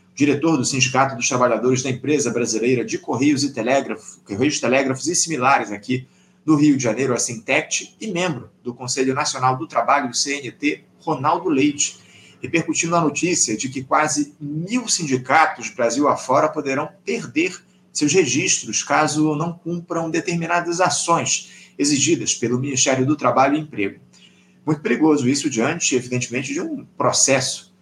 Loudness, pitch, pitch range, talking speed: -19 LUFS, 145 Hz, 130-170 Hz, 145 wpm